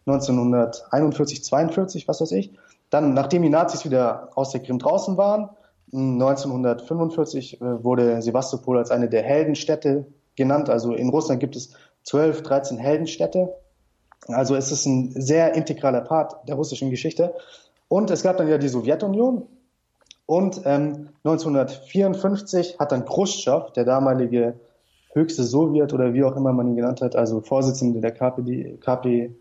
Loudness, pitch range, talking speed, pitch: -22 LUFS, 125-160 Hz, 145 wpm, 140 Hz